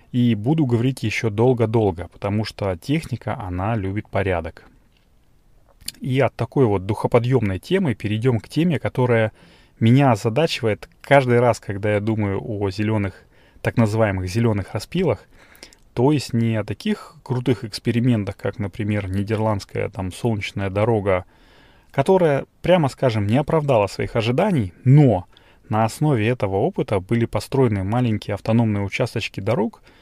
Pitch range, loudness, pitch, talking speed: 105-130 Hz, -21 LUFS, 115 Hz, 130 wpm